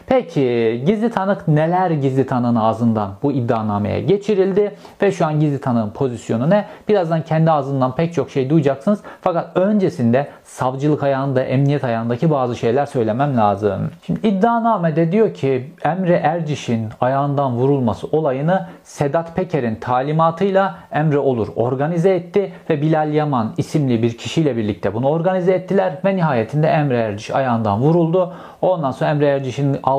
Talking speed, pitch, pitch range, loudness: 140 wpm, 150 Hz, 130-185 Hz, -18 LUFS